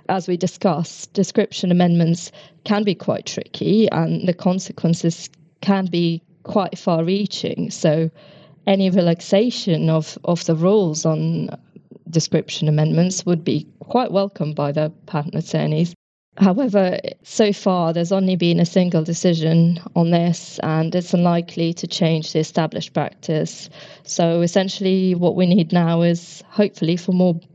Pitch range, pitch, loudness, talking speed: 165-190 Hz, 175 Hz, -19 LUFS, 140 wpm